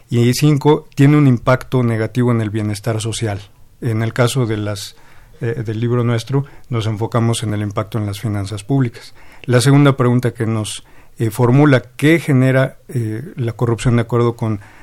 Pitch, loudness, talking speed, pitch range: 120 Hz, -16 LUFS, 175 wpm, 110-130 Hz